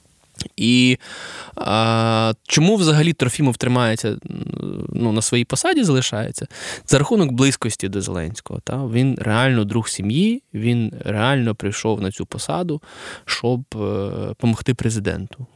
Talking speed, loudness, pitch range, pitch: 120 wpm, -20 LUFS, 110-135 Hz, 120 Hz